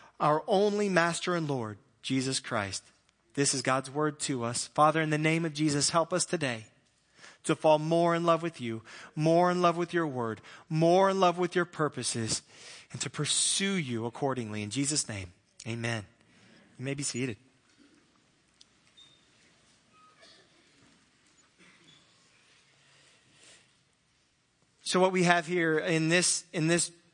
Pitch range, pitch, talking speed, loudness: 125-170 Hz, 150 Hz, 140 wpm, -29 LUFS